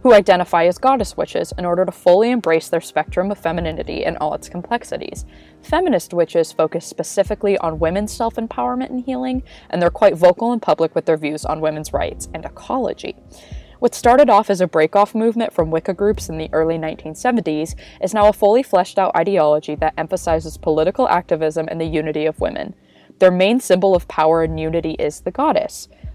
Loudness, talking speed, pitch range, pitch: -18 LUFS, 185 wpm, 160-210 Hz, 175 Hz